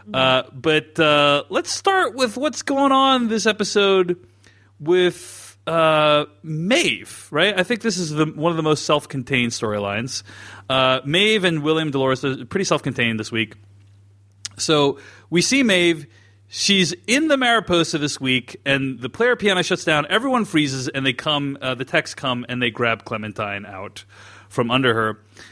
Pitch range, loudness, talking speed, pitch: 115-180 Hz, -19 LUFS, 160 wpm, 145 Hz